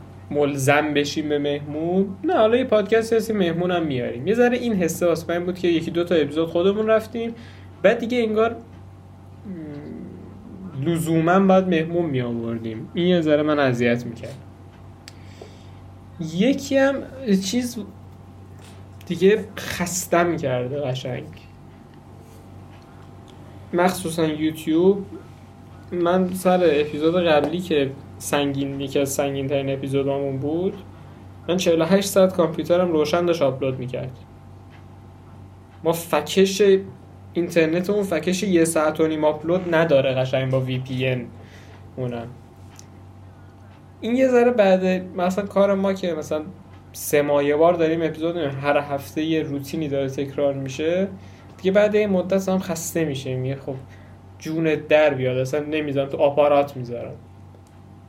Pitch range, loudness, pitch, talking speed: 115-175 Hz, -21 LUFS, 145 Hz, 125 wpm